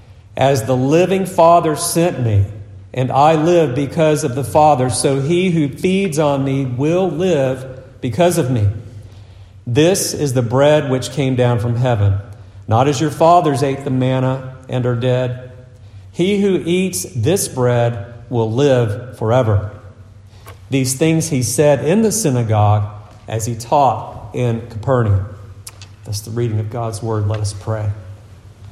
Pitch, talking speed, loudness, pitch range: 125 Hz, 150 wpm, -16 LUFS, 105-150 Hz